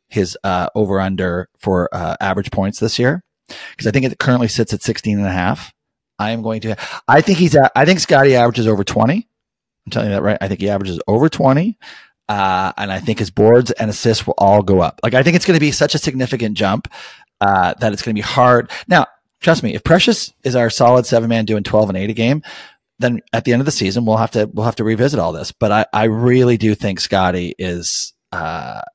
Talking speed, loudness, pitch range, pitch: 245 wpm, -15 LUFS, 105-130 Hz, 115 Hz